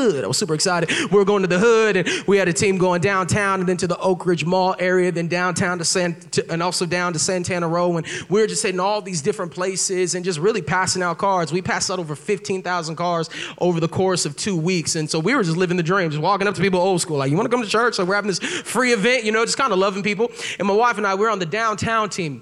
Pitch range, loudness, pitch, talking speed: 175-205 Hz, -20 LUFS, 185 Hz, 285 wpm